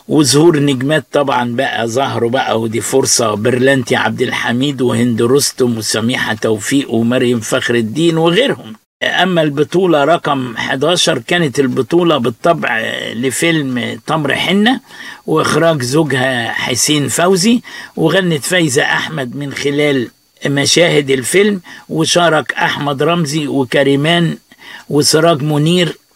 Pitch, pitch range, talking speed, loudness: 140 Hz, 125-165 Hz, 105 wpm, -13 LUFS